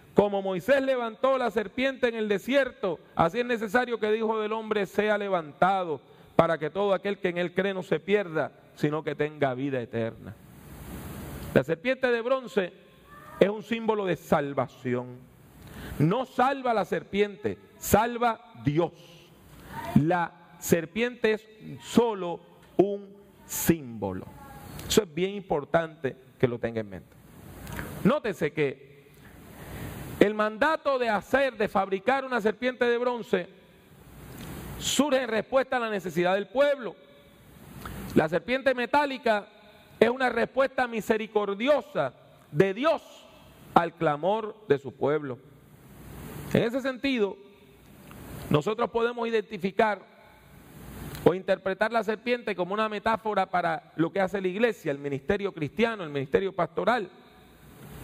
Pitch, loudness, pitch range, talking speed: 200 Hz, -27 LUFS, 165-235 Hz, 130 wpm